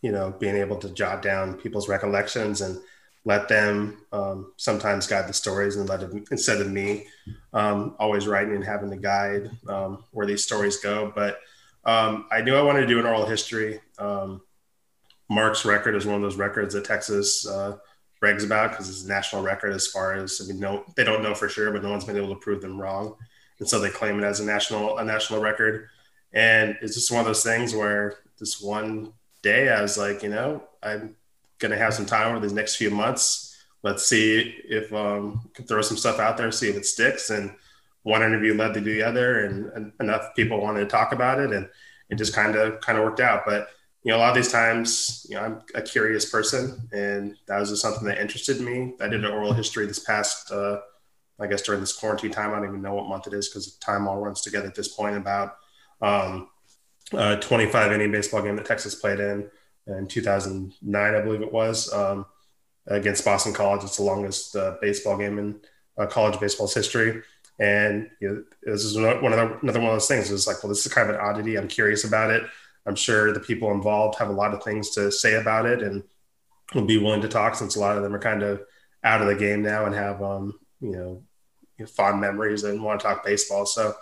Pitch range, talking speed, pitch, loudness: 100-110 Hz, 225 wpm, 105 Hz, -24 LUFS